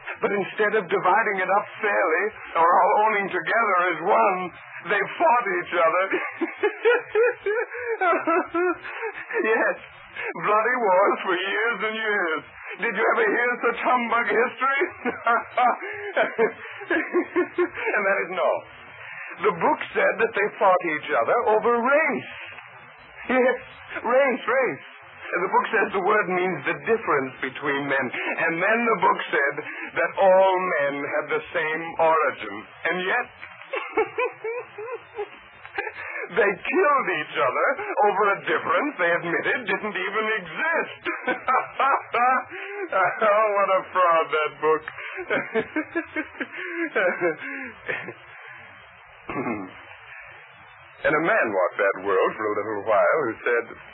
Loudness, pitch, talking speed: -23 LUFS, 235 Hz, 115 wpm